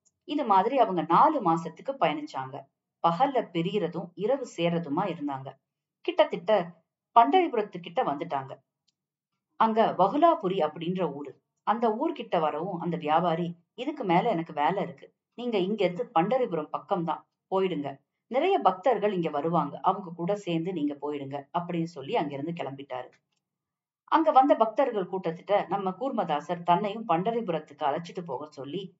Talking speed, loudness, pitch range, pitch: 120 wpm, -28 LUFS, 155-210 Hz, 170 Hz